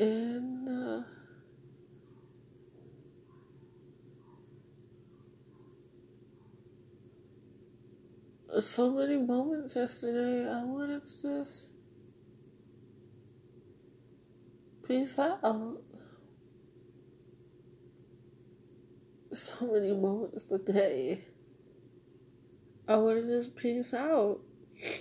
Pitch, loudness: 215 Hz, -33 LUFS